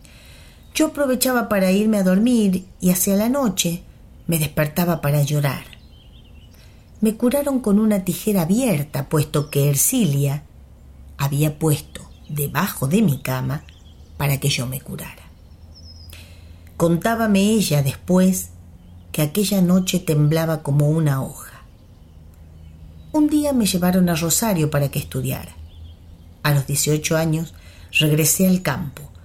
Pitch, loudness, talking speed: 150 Hz, -19 LUFS, 125 wpm